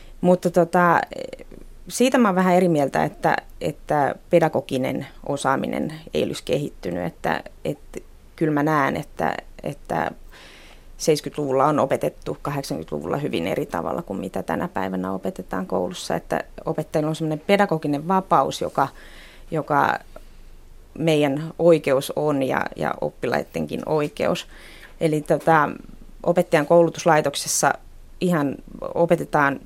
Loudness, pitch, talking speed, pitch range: -22 LUFS, 155 Hz, 110 wpm, 140-175 Hz